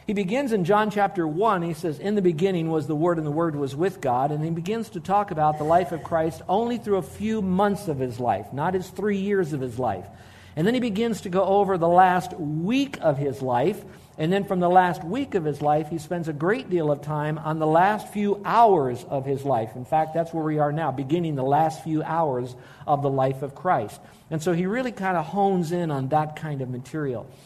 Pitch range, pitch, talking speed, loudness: 145-195 Hz, 165 Hz, 245 wpm, -24 LUFS